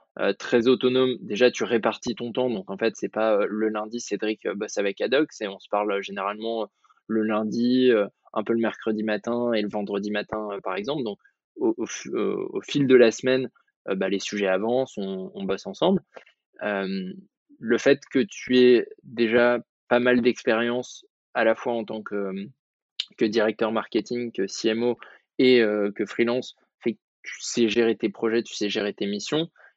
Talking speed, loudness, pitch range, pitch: 200 wpm, -25 LUFS, 105-125 Hz, 115 Hz